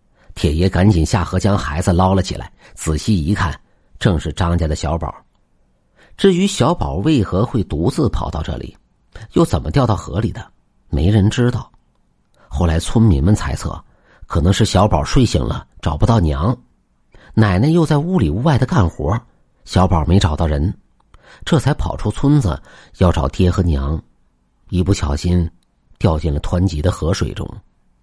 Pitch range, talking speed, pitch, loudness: 80-105 Hz, 235 characters per minute, 90 Hz, -17 LUFS